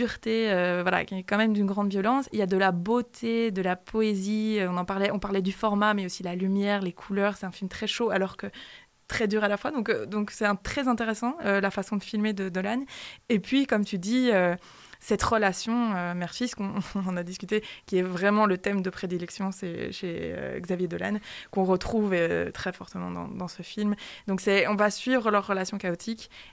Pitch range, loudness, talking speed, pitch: 190-220 Hz, -28 LUFS, 220 wpm, 200 Hz